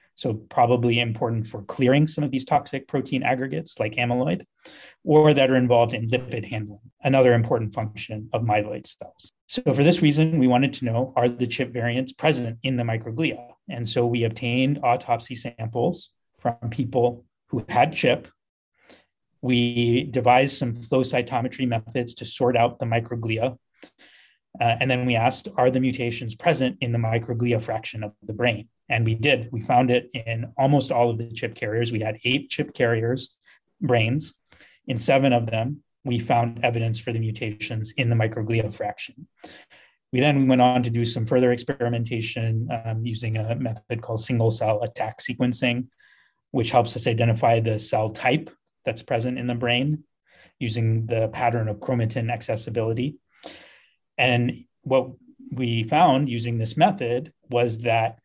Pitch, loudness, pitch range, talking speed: 120 Hz, -23 LUFS, 115-130 Hz, 165 wpm